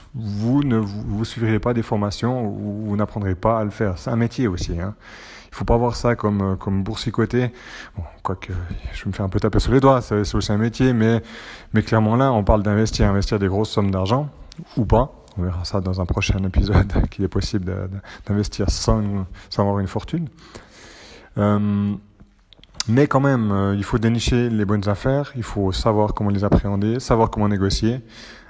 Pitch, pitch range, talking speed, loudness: 105 Hz, 100-115 Hz, 200 wpm, -21 LUFS